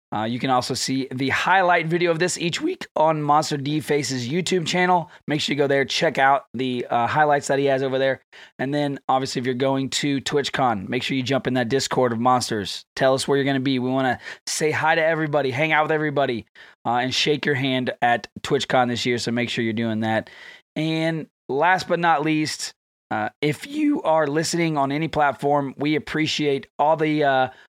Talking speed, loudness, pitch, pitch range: 220 wpm, -22 LUFS, 140 Hz, 130-155 Hz